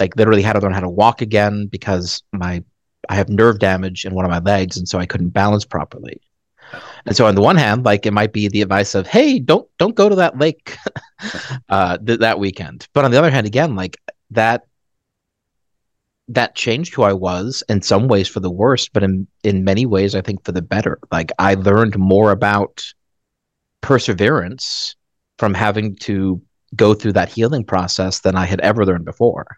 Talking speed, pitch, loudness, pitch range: 200 wpm, 100 Hz, -16 LUFS, 95-110 Hz